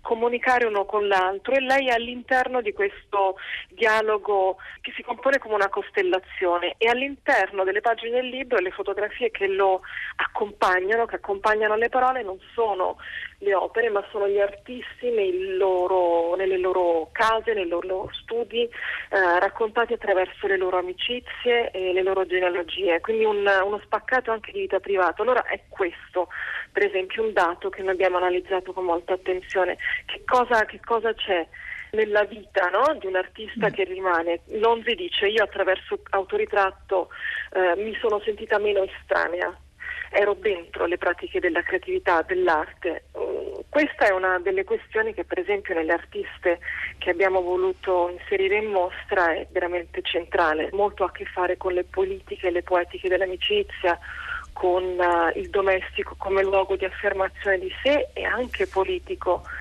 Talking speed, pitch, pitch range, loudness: 155 wpm, 200 Hz, 185-235 Hz, -24 LUFS